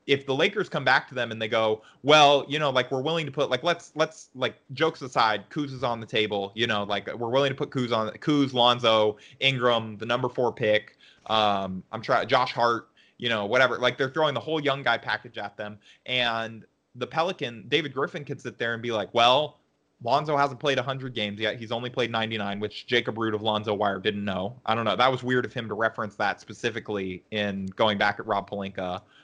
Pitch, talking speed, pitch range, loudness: 120 Hz, 230 wpm, 105-135 Hz, -26 LUFS